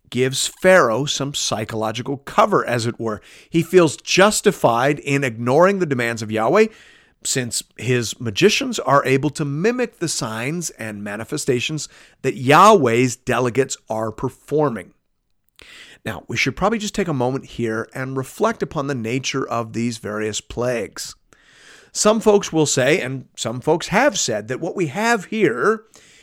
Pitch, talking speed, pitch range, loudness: 135 Hz, 150 wpm, 120-175 Hz, -19 LUFS